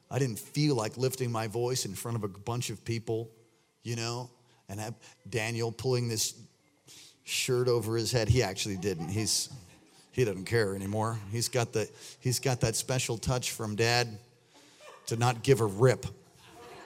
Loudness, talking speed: -31 LUFS, 170 wpm